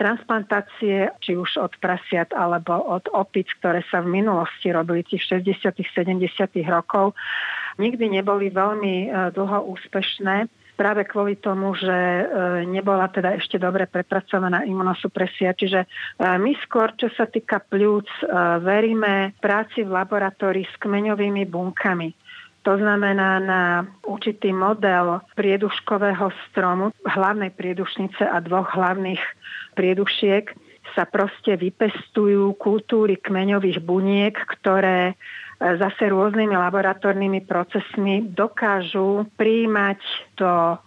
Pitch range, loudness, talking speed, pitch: 185-205 Hz, -22 LUFS, 105 wpm, 195 Hz